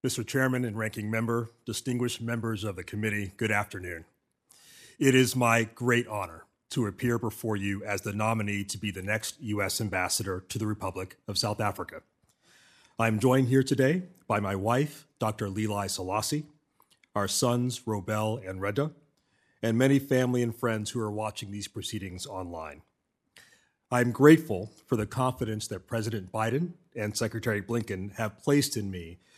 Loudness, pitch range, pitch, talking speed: -29 LUFS, 105-125 Hz, 110 Hz, 160 wpm